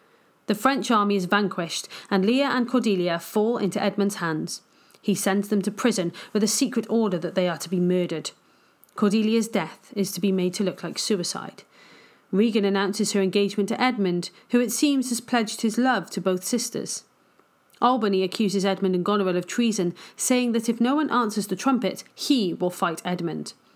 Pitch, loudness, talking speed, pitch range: 205 Hz, -24 LUFS, 185 wpm, 185-235 Hz